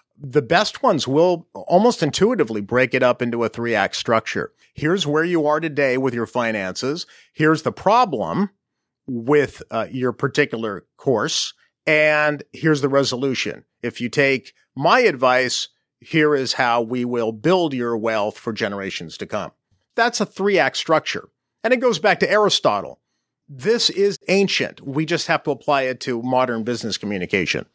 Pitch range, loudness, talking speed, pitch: 125-170 Hz, -20 LUFS, 160 wpm, 145 Hz